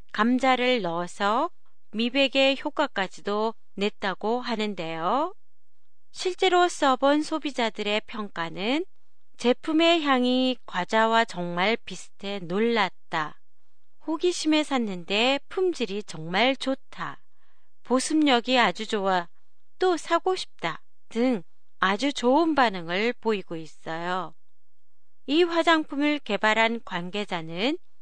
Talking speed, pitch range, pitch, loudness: 220 characters per minute, 200-290 Hz, 235 Hz, -25 LUFS